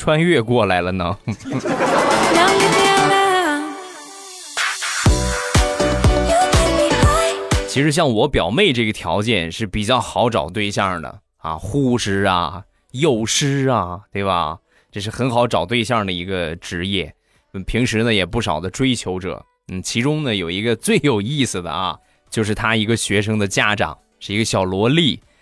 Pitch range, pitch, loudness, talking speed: 95-125 Hz, 110 Hz, -18 LUFS, 200 characters per minute